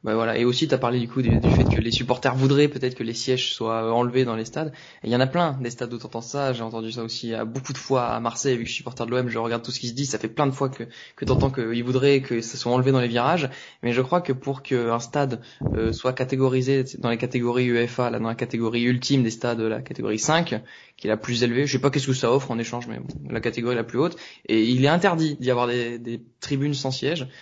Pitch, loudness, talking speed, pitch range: 125 Hz, -24 LUFS, 285 wpm, 115-135 Hz